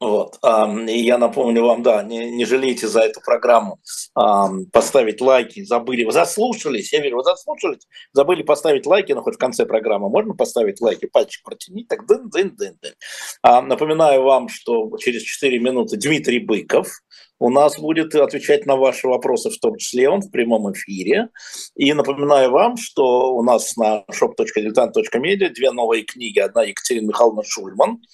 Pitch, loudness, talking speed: 140 Hz, -17 LUFS, 155 wpm